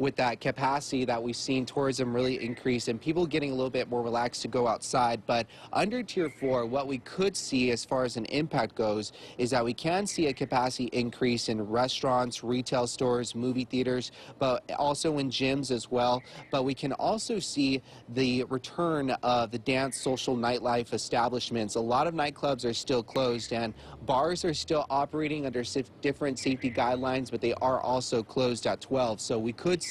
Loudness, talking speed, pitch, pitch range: -30 LUFS, 190 wpm, 125 Hz, 120-140 Hz